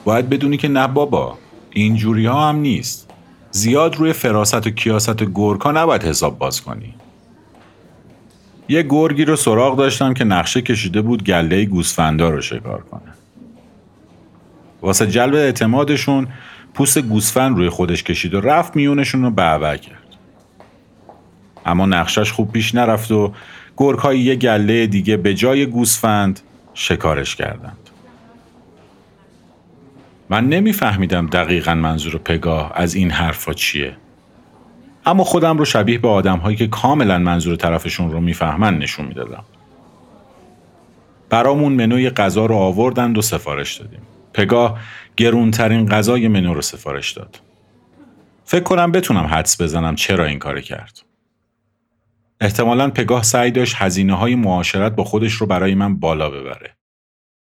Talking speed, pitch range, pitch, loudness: 130 wpm, 95-125 Hz, 110 Hz, -16 LUFS